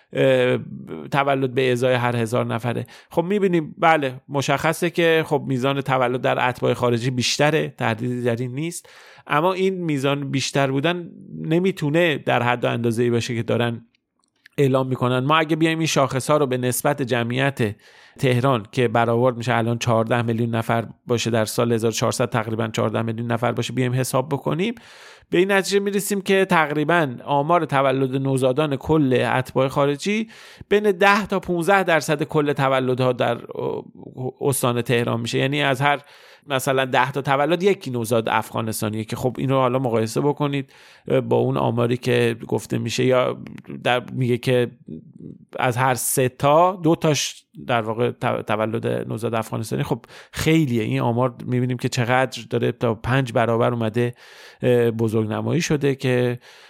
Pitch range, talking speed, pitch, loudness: 120-145 Hz, 150 wpm, 130 Hz, -21 LUFS